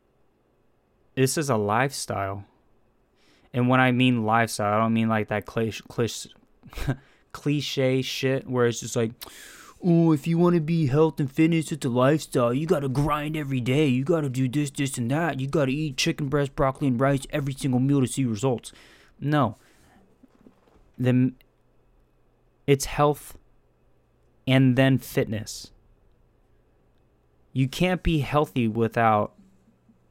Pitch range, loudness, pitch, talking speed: 120-150 Hz, -24 LUFS, 135 Hz, 145 wpm